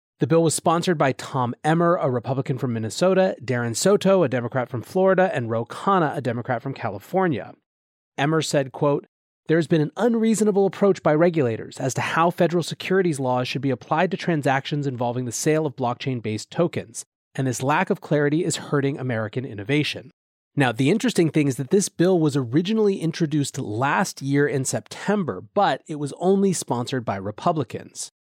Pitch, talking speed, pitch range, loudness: 145 Hz, 180 wpm, 130-175 Hz, -22 LUFS